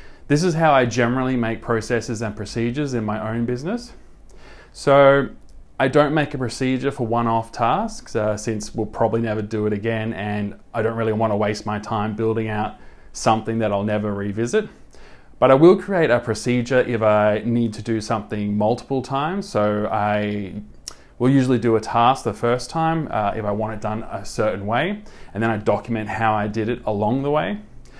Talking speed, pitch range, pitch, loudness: 195 wpm, 105-130 Hz, 115 Hz, -21 LUFS